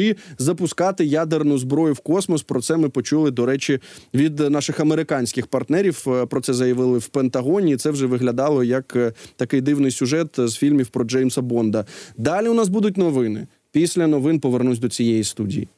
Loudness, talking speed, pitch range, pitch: -20 LUFS, 165 wpm, 125-155 Hz, 135 Hz